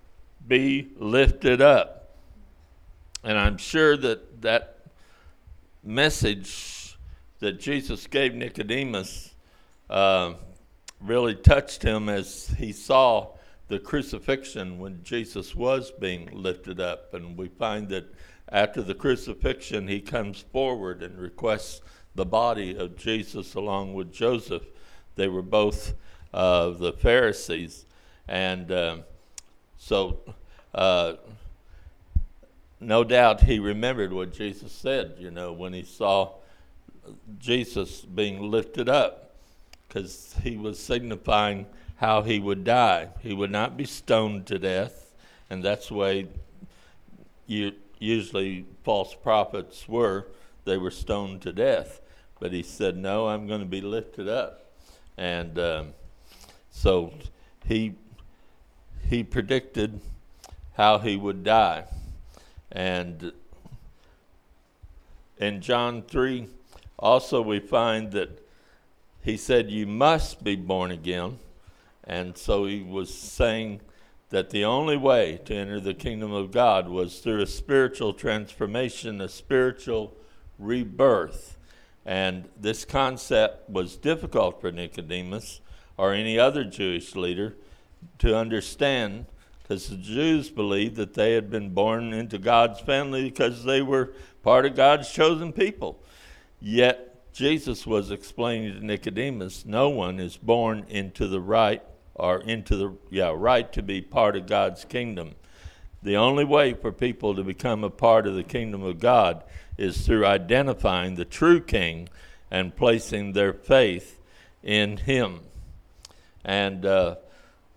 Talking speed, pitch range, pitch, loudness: 125 wpm, 90-115 Hz, 100 Hz, -25 LUFS